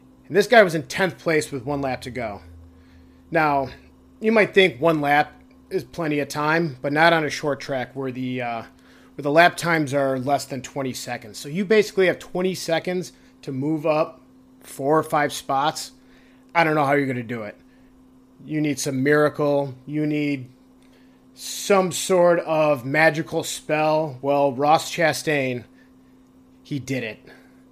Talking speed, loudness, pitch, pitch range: 170 wpm, -22 LUFS, 145 Hz, 130-160 Hz